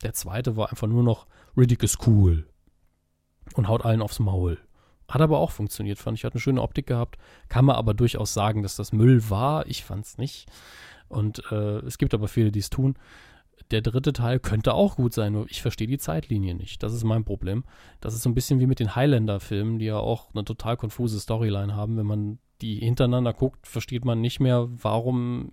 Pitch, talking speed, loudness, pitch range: 115 Hz, 210 wpm, -25 LUFS, 105-125 Hz